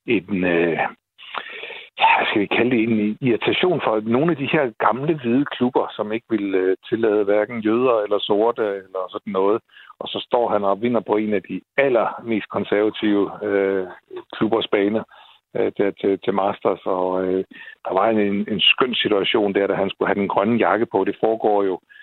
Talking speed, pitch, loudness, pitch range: 190 wpm, 105 Hz, -20 LUFS, 95-115 Hz